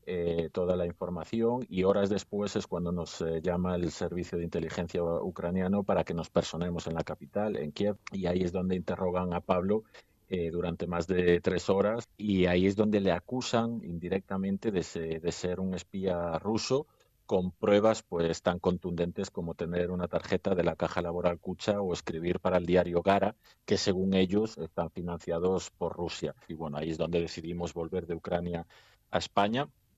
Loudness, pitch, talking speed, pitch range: -31 LUFS, 90 Hz, 180 wpm, 85-95 Hz